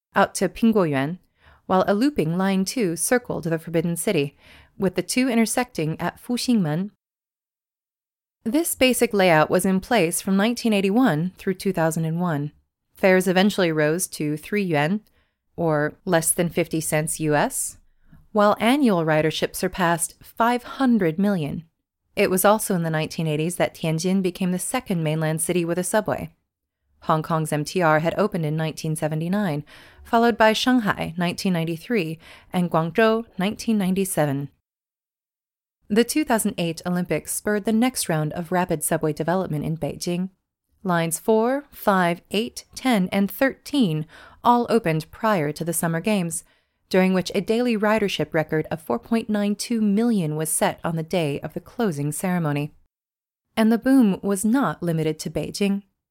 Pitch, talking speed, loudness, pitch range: 180 Hz, 145 wpm, -22 LUFS, 160-215 Hz